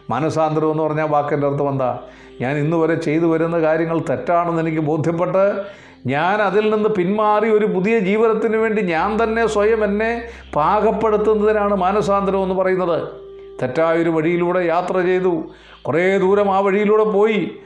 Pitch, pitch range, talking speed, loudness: 185 Hz, 160-210 Hz, 135 wpm, -18 LUFS